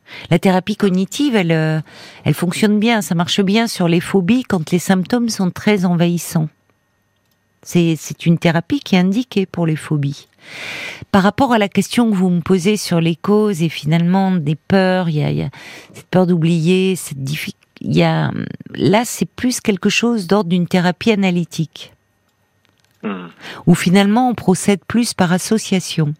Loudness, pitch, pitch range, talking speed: -16 LUFS, 180 Hz, 160-205 Hz, 165 wpm